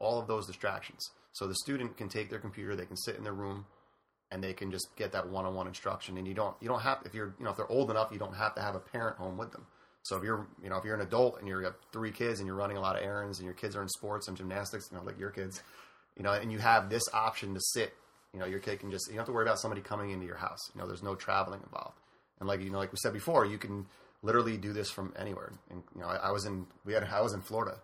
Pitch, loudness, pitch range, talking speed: 100 Hz, -36 LUFS, 95-110 Hz, 310 wpm